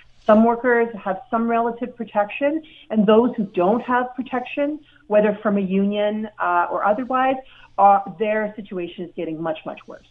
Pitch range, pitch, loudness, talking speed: 200-245 Hz, 215 Hz, -21 LUFS, 160 wpm